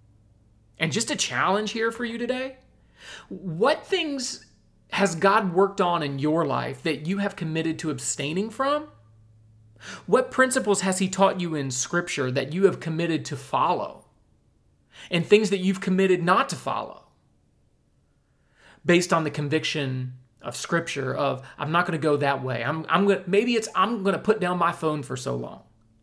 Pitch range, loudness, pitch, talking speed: 140-200 Hz, -24 LUFS, 170 Hz, 175 wpm